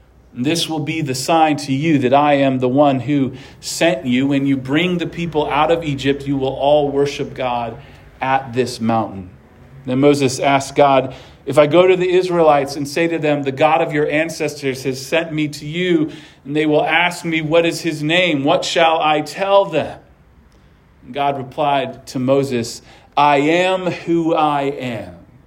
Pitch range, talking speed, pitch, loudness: 135-160 Hz, 190 wpm, 145 Hz, -17 LUFS